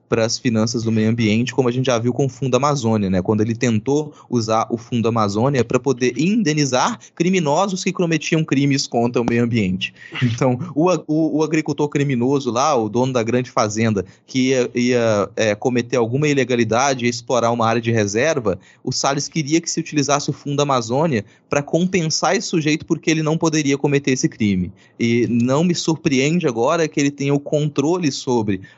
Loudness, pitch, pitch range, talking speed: -19 LUFS, 135 Hz, 115-150 Hz, 190 wpm